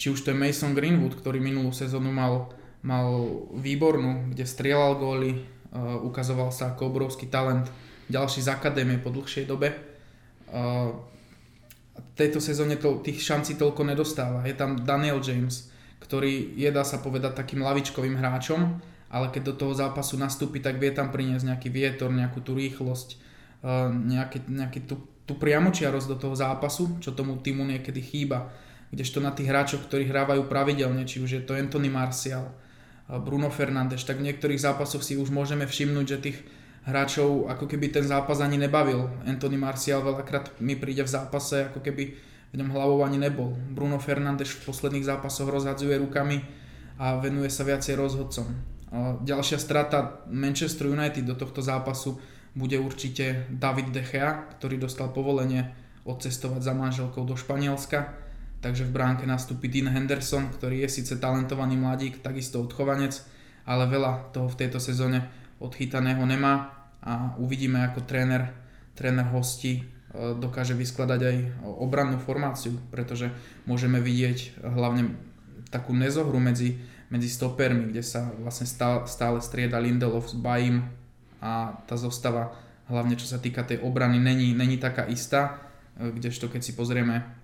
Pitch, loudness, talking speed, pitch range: 130 Hz, -28 LUFS, 150 wpm, 125-140 Hz